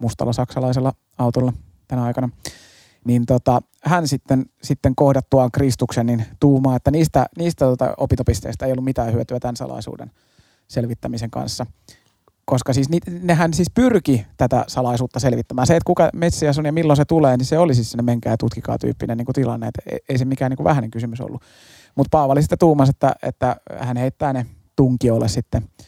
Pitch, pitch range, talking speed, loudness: 130 Hz, 120-140 Hz, 170 wpm, -19 LUFS